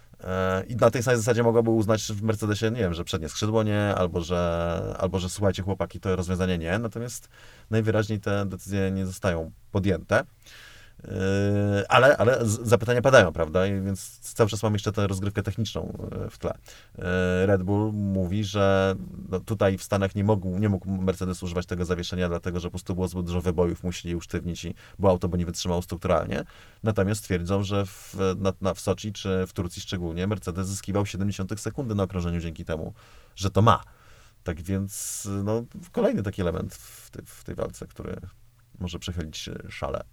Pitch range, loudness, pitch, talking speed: 90-110 Hz, -26 LUFS, 95 Hz, 175 wpm